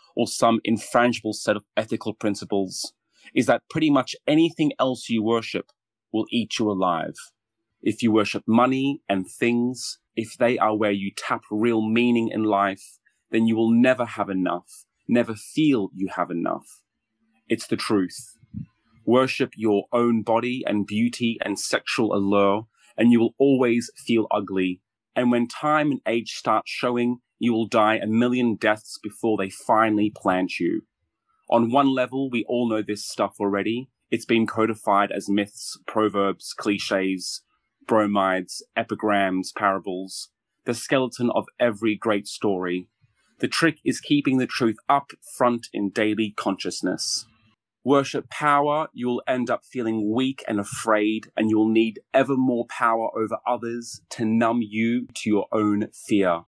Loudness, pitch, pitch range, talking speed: -23 LUFS, 115 Hz, 105-120 Hz, 155 wpm